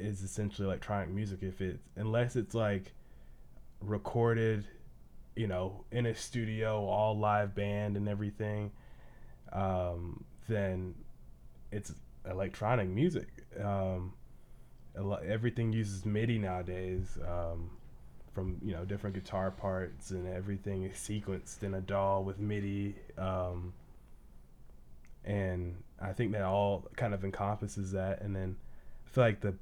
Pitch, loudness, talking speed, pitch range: 95 Hz, -36 LUFS, 130 wpm, 90-105 Hz